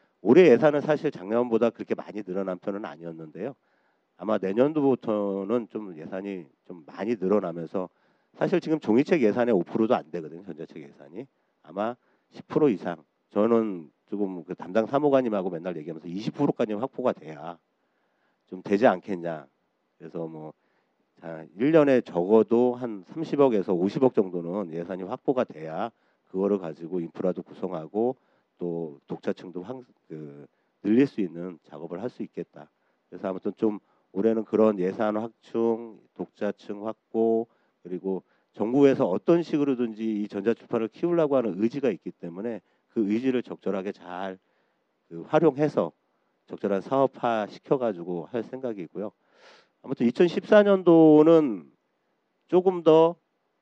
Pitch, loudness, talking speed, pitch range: 110 Hz, -25 LUFS, 290 characters per minute, 90-130 Hz